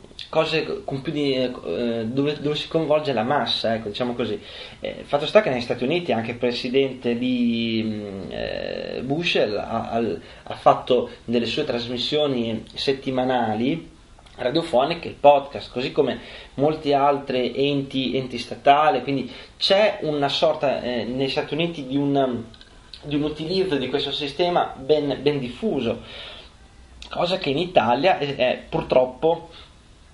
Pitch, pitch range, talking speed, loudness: 135 Hz, 120-145 Hz, 145 wpm, -23 LUFS